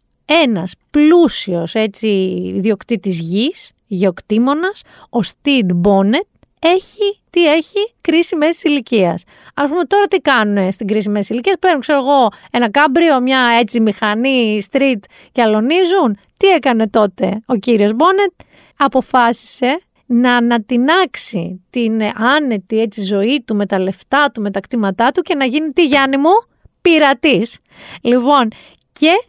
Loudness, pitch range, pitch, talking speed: -14 LUFS, 210-310 Hz, 245 Hz, 135 wpm